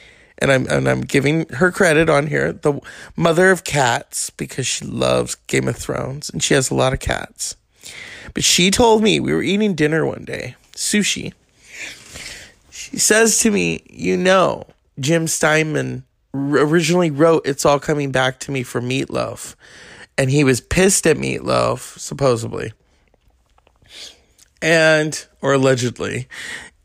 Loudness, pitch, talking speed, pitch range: -17 LUFS, 150 Hz, 145 wpm, 130-180 Hz